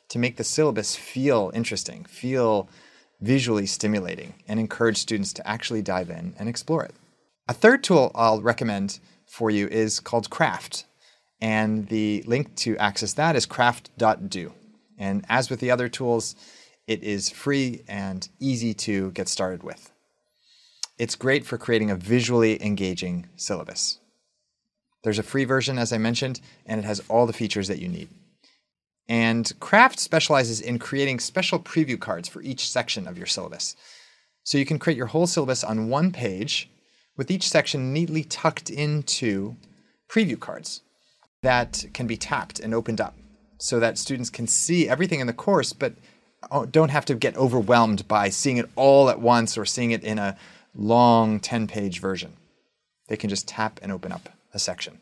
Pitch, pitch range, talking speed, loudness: 115 Hz, 110-135 Hz, 170 wpm, -24 LUFS